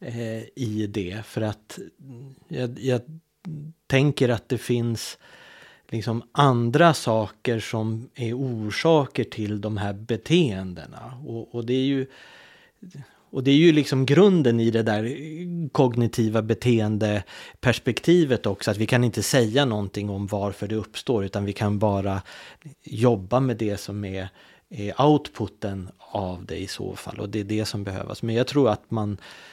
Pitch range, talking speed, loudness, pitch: 105-135 Hz, 150 wpm, -24 LUFS, 115 Hz